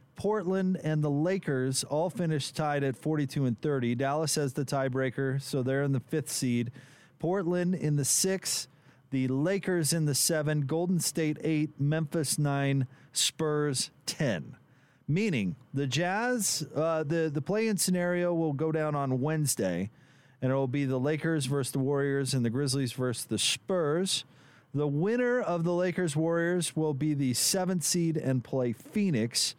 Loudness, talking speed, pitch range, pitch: -29 LUFS, 160 wpm, 135-170 Hz, 150 Hz